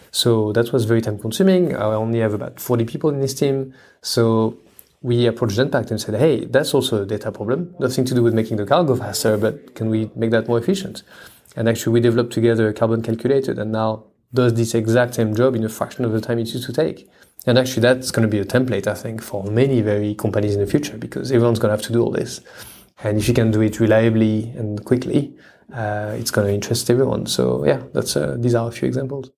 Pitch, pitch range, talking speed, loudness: 115 Hz, 110-125 Hz, 240 wpm, -19 LUFS